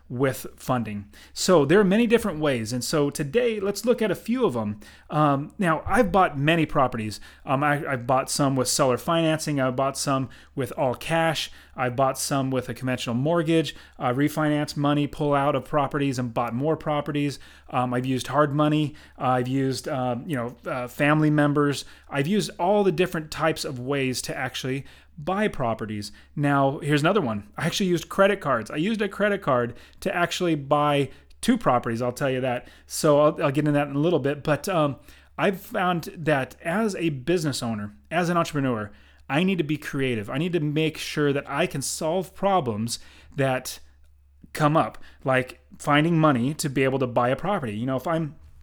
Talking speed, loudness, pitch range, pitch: 195 wpm, -24 LUFS, 125-165 Hz, 145 Hz